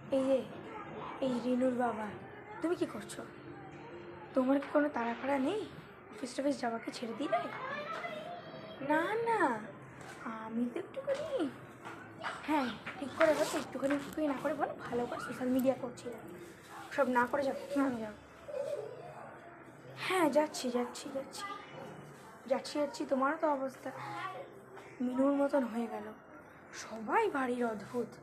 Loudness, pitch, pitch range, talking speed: -35 LUFS, 275 Hz, 250-300 Hz, 125 wpm